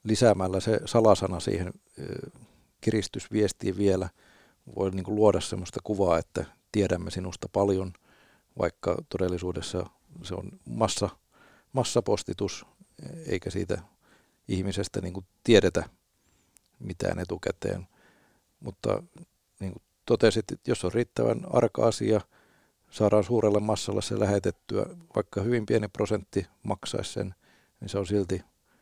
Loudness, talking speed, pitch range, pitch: -28 LUFS, 115 wpm, 95-110 Hz, 100 Hz